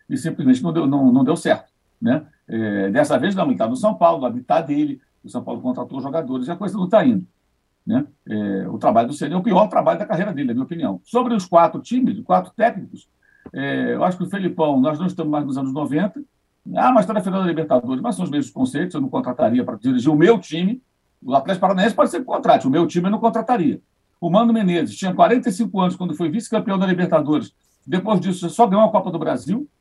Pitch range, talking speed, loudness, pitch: 165-240 Hz, 240 wpm, -19 LUFS, 195 Hz